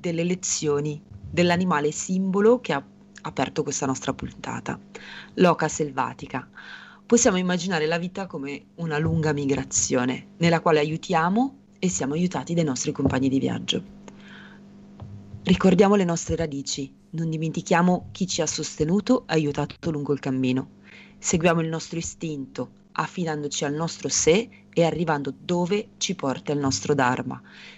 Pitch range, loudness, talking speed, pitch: 145-185 Hz, -24 LUFS, 135 wpm, 165 Hz